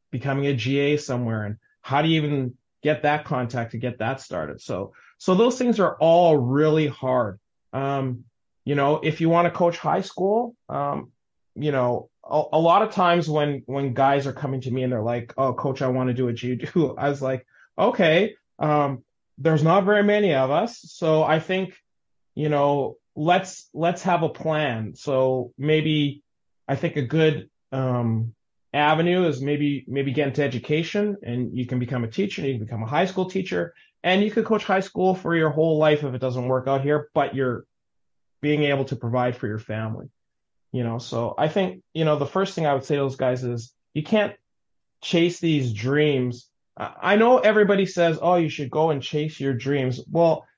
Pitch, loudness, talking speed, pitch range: 145 Hz, -23 LUFS, 200 wpm, 125-165 Hz